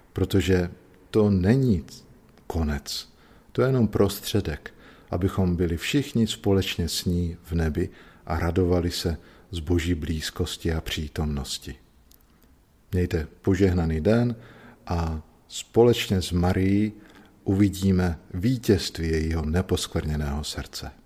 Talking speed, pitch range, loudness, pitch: 105 wpm, 80-100 Hz, -25 LUFS, 90 Hz